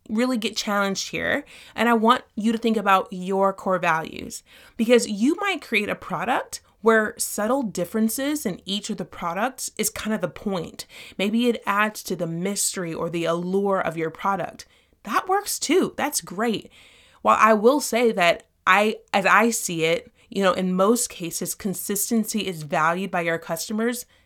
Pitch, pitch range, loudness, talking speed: 210 Hz, 185-235 Hz, -23 LUFS, 175 wpm